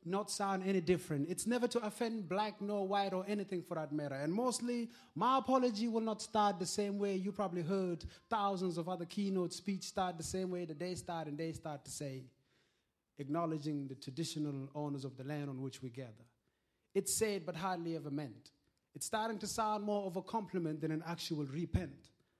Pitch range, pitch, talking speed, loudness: 150-205 Hz, 180 Hz, 200 wpm, -39 LUFS